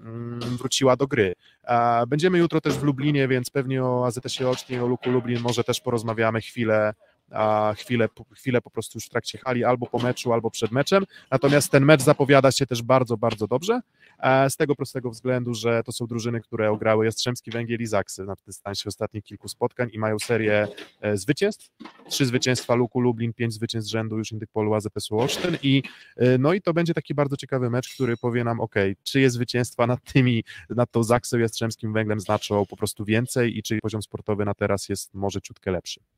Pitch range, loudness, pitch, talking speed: 110-130 Hz, -24 LUFS, 120 Hz, 185 wpm